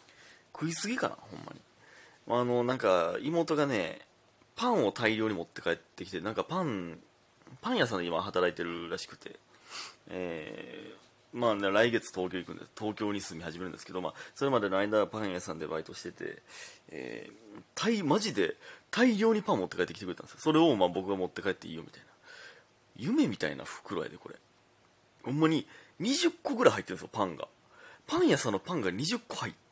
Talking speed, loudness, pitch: 380 characters per minute, -32 LUFS, 110 Hz